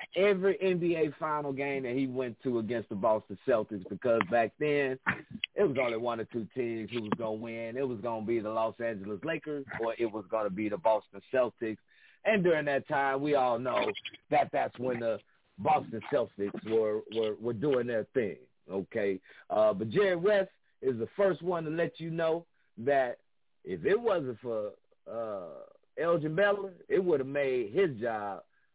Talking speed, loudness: 190 wpm, -31 LUFS